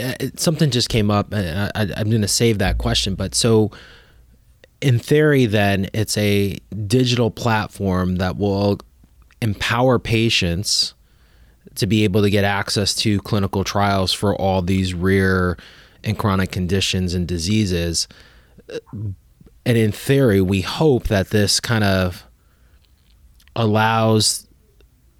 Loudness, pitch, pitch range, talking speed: -19 LUFS, 100 Hz, 95-110 Hz, 125 wpm